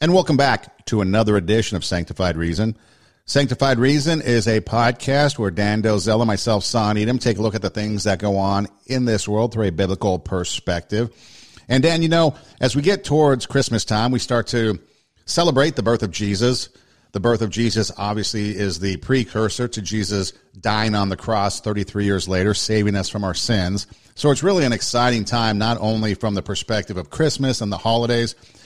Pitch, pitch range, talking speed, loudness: 110 Hz, 100-120 Hz, 195 wpm, -20 LUFS